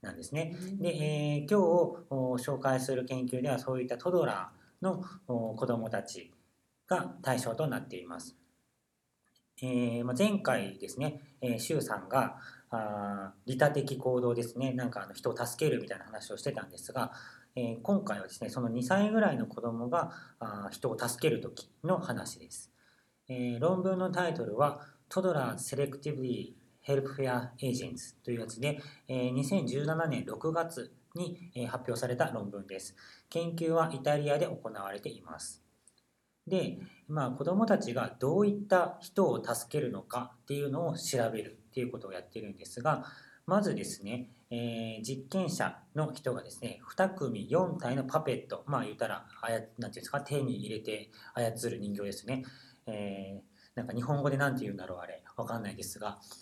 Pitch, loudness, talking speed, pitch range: 130 Hz, -34 LUFS, 320 characters per minute, 120-155 Hz